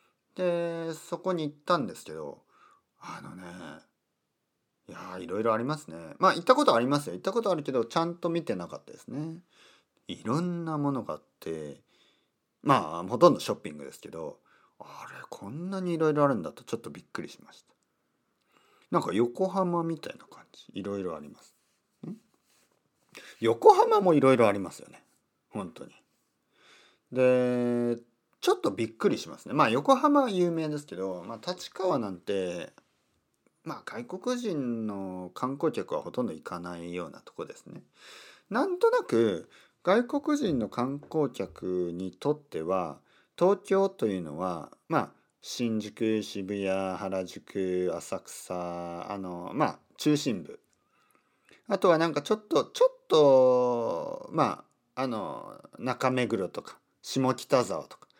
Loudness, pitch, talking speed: -29 LUFS, 145 Hz, 285 characters per minute